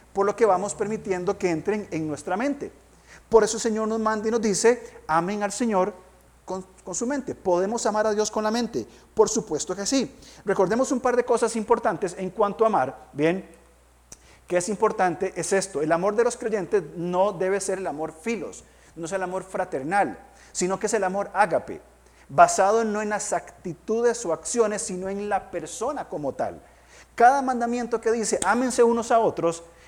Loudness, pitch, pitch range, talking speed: -24 LUFS, 205 Hz, 185-230 Hz, 195 wpm